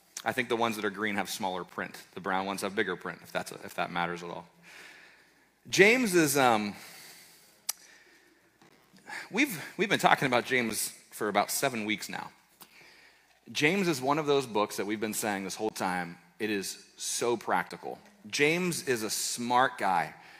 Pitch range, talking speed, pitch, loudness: 100-140 Hz, 175 wpm, 110 Hz, -29 LUFS